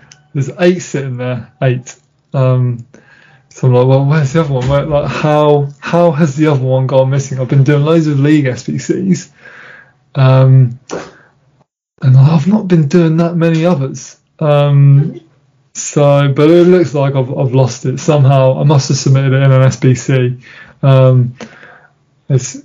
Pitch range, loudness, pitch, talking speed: 130-155 Hz, -11 LUFS, 140 Hz, 160 wpm